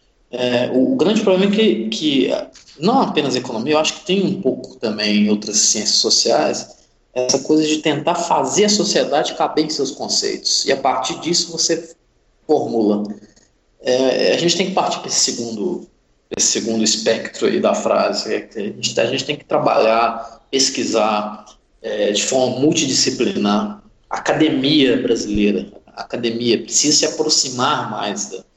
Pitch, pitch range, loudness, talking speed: 130 Hz, 110-165 Hz, -17 LUFS, 160 wpm